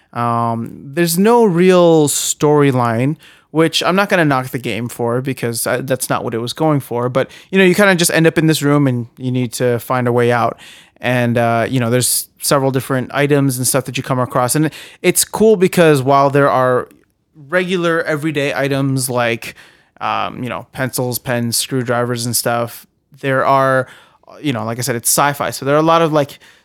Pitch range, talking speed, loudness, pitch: 120-155 Hz, 205 wpm, -15 LUFS, 135 Hz